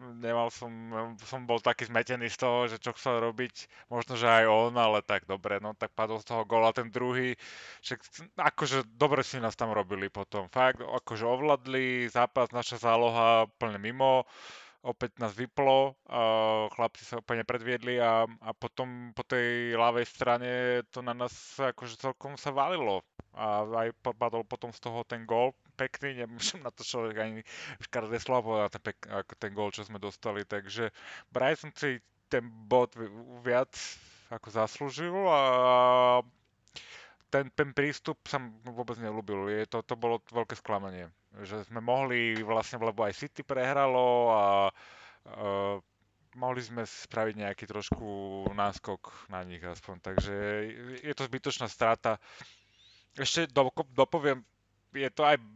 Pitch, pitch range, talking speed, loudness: 120 Hz, 110-125 Hz, 150 wpm, -31 LUFS